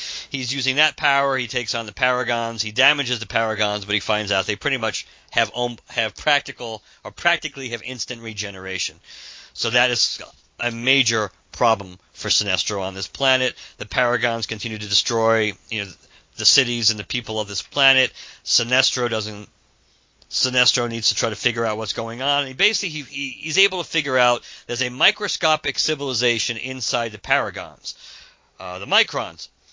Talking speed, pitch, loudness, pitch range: 170 wpm, 120 Hz, -20 LUFS, 110-135 Hz